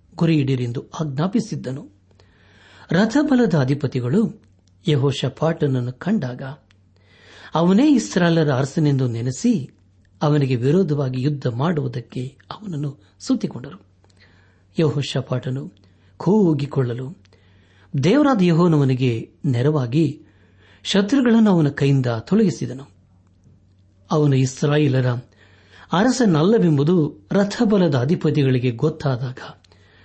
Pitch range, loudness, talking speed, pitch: 100-165 Hz, -20 LUFS, 65 wpm, 135 Hz